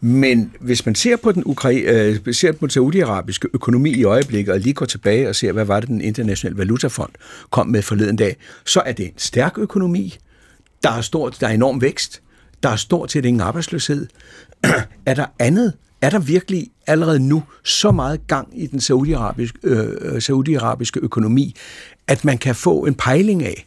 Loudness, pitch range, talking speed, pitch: -18 LUFS, 115-155 Hz, 190 wpm, 130 Hz